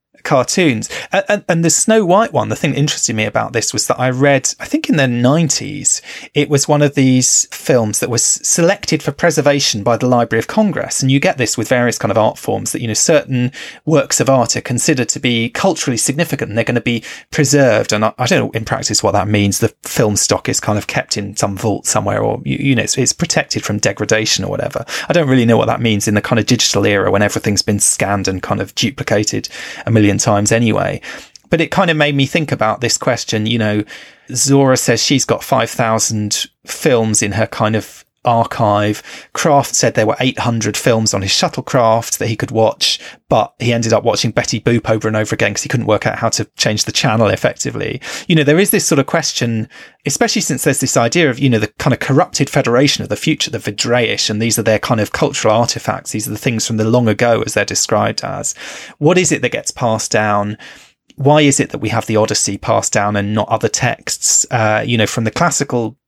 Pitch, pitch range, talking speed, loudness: 120 Hz, 110-140 Hz, 235 wpm, -14 LUFS